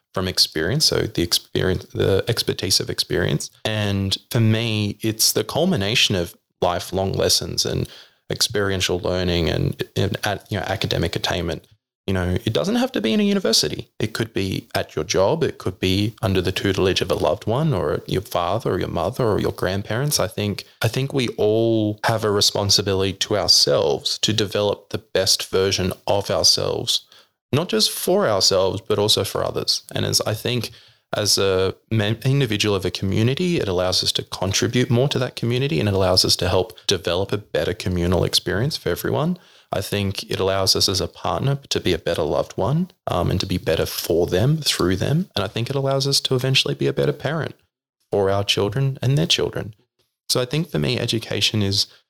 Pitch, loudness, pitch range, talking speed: 110 Hz, -20 LUFS, 95-130 Hz, 195 wpm